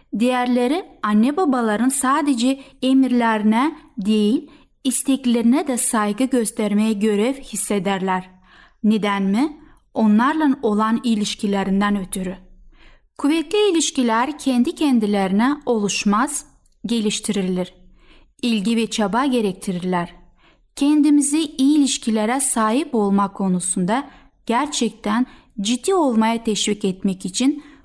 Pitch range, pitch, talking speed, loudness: 210-270 Hz, 230 Hz, 85 wpm, -19 LUFS